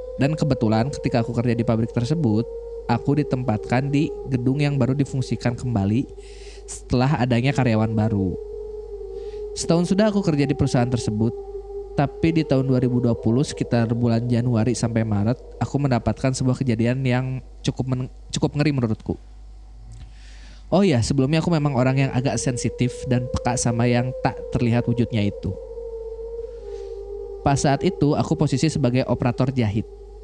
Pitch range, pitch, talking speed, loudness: 120-160 Hz, 130 Hz, 140 wpm, -22 LUFS